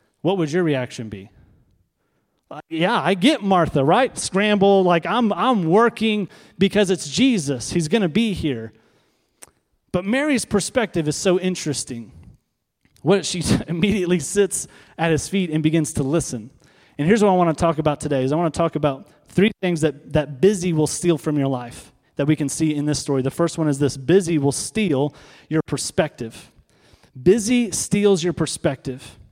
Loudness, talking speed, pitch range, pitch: -20 LUFS, 175 wpm, 140-195 Hz, 165 Hz